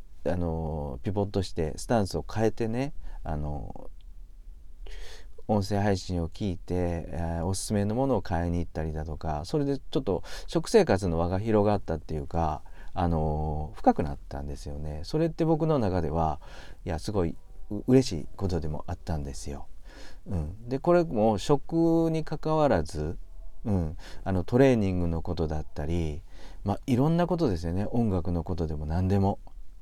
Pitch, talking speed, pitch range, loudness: 85 Hz, 320 characters per minute, 80-105 Hz, -29 LUFS